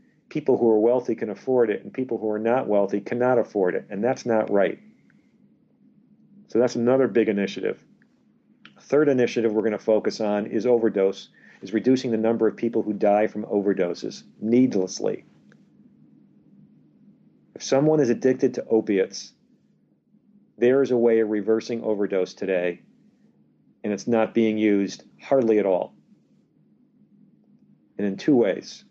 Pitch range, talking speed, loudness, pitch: 105-135 Hz, 145 wpm, -23 LUFS, 115 Hz